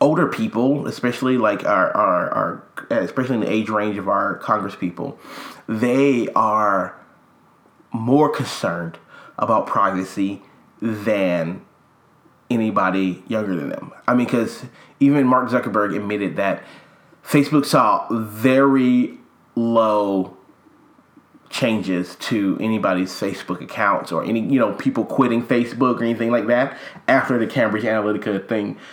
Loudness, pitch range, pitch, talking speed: -20 LUFS, 105-125 Hz, 115 Hz, 125 wpm